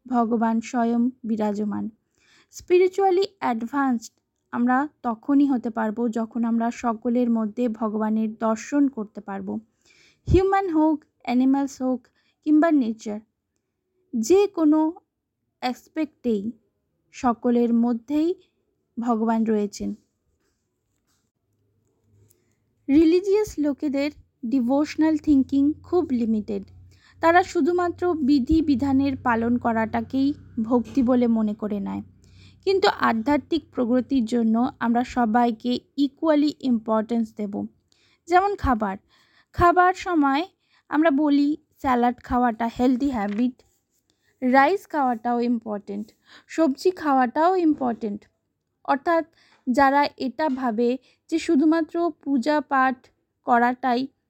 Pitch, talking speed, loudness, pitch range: 250 Hz, 90 wpm, -23 LUFS, 230-300 Hz